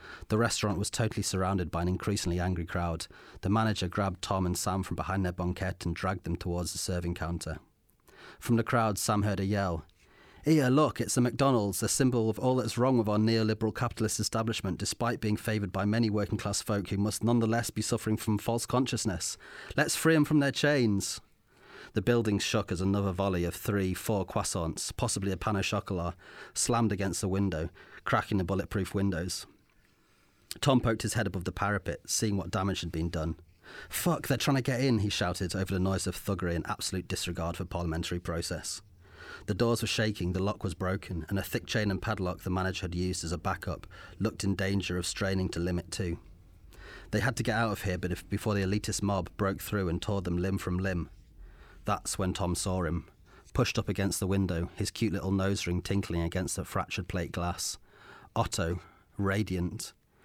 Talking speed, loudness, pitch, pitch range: 195 wpm, -31 LUFS, 95 Hz, 90-110 Hz